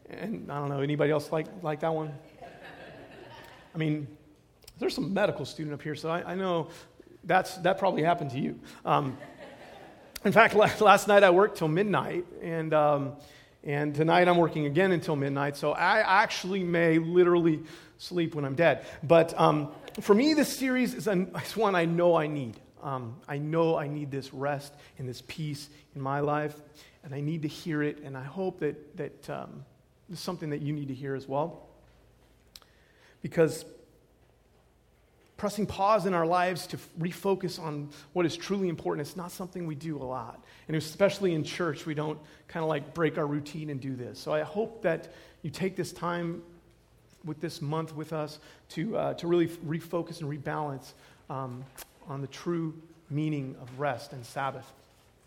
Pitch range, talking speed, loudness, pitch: 145-175 Hz, 180 wpm, -29 LUFS, 155 Hz